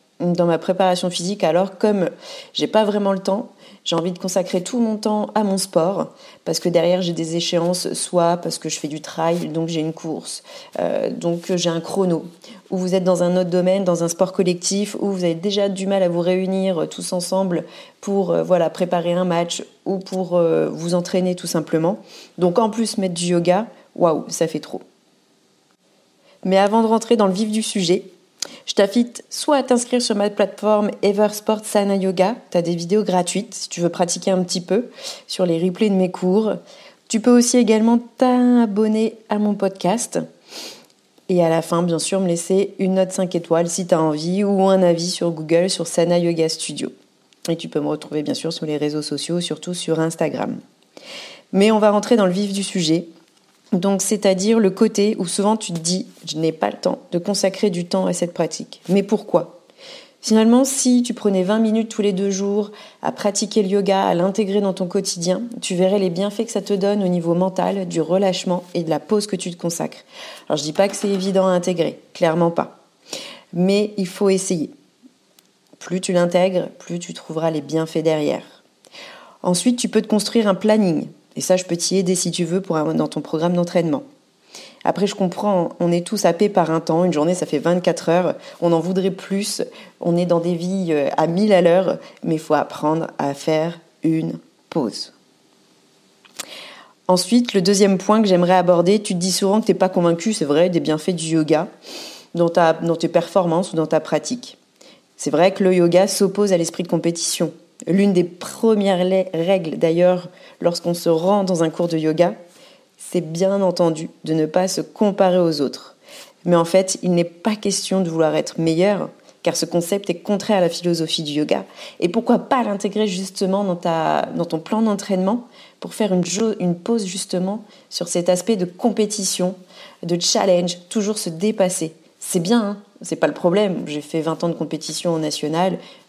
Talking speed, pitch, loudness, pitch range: 200 wpm, 185 Hz, -19 LUFS, 170-205 Hz